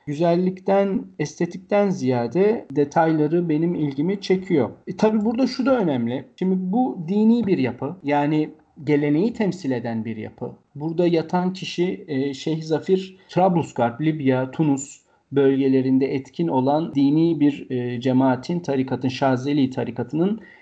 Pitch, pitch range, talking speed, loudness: 155 Hz, 135-185 Hz, 120 wpm, -22 LUFS